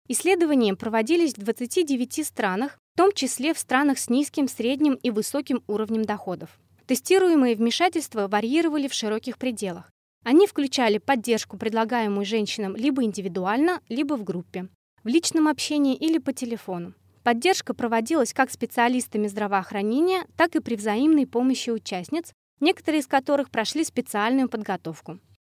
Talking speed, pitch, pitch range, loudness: 130 wpm, 250 Hz, 215-295 Hz, -24 LUFS